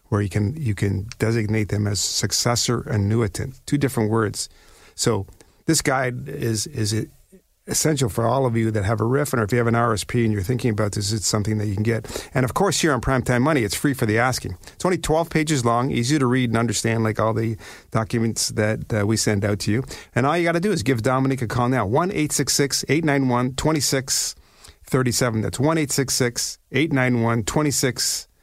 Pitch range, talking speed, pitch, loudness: 110-140 Hz, 235 wpm, 120 Hz, -21 LUFS